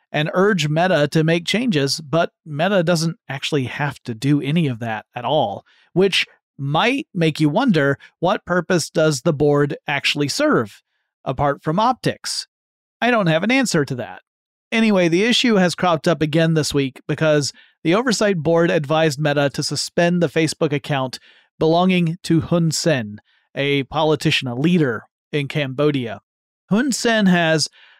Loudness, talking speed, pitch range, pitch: -19 LUFS, 155 wpm, 145-175 Hz, 160 Hz